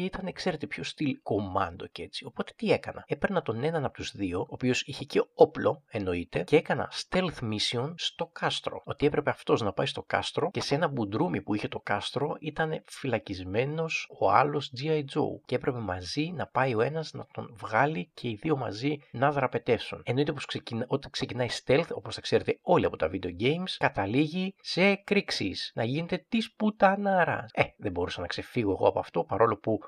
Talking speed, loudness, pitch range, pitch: 195 wpm, -29 LUFS, 115-165 Hz, 145 Hz